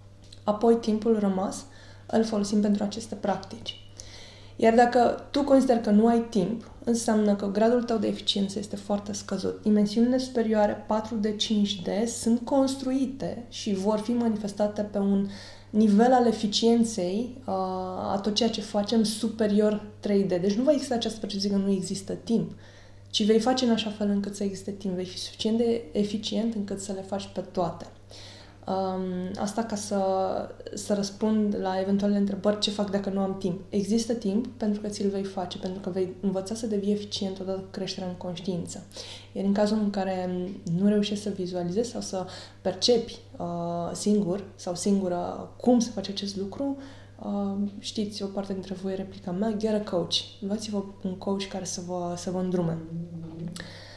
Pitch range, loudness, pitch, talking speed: 190-220 Hz, -27 LUFS, 205 Hz, 170 wpm